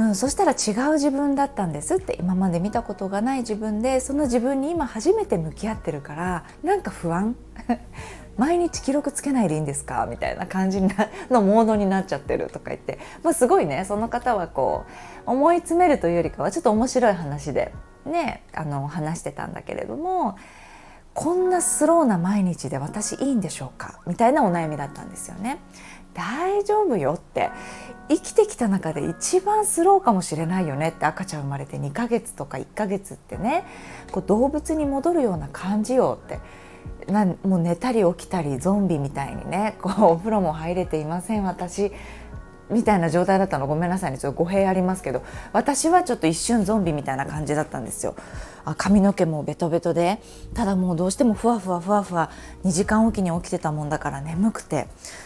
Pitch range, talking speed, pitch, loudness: 170-250 Hz, 390 characters per minute, 200 Hz, -23 LUFS